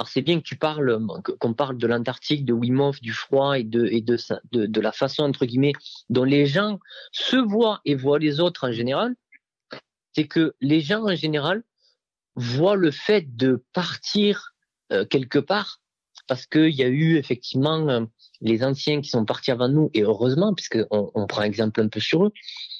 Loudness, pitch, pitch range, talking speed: -23 LUFS, 140 Hz, 120-175 Hz, 190 wpm